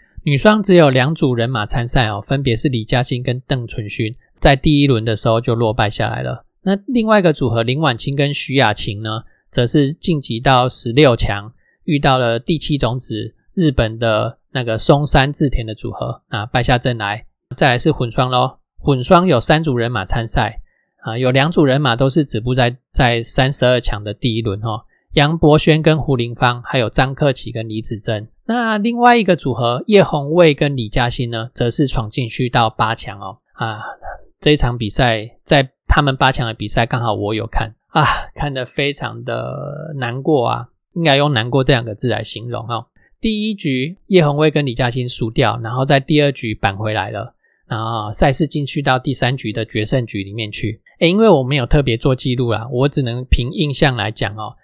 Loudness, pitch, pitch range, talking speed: -16 LUFS, 130 Hz, 115-145 Hz, 285 characters per minute